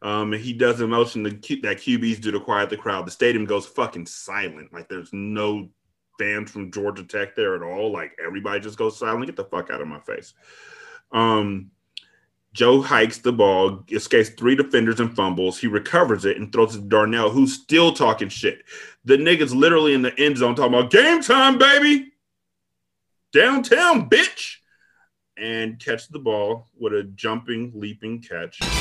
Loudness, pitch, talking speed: -20 LUFS, 120 Hz, 180 wpm